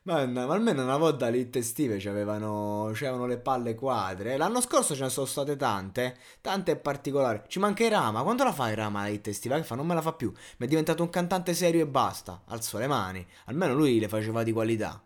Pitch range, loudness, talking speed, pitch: 110-160 Hz, -28 LUFS, 225 wpm, 130 Hz